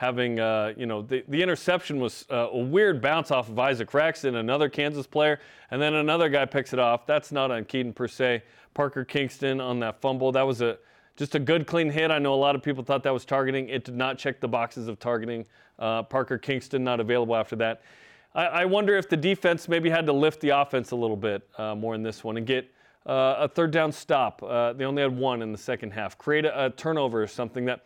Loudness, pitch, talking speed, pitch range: -26 LUFS, 130 Hz, 245 wpm, 120-145 Hz